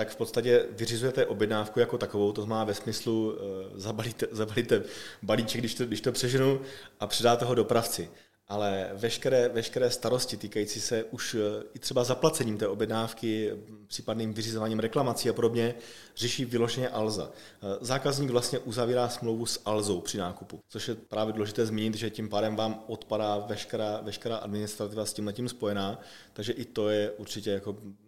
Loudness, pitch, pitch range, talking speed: -30 LUFS, 110 Hz, 105-120 Hz, 160 wpm